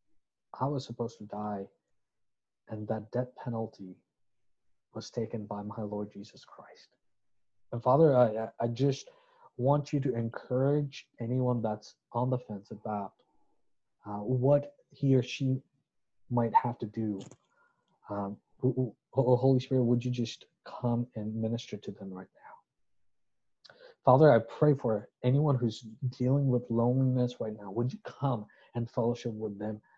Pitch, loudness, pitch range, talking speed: 120 Hz, -31 LUFS, 110-130 Hz, 145 wpm